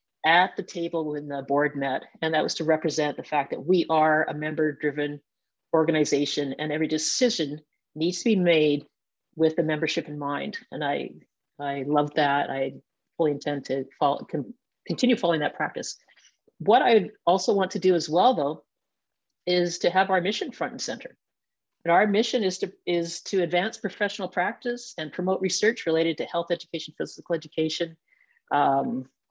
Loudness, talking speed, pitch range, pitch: -25 LUFS, 170 wpm, 150-185 Hz, 165 Hz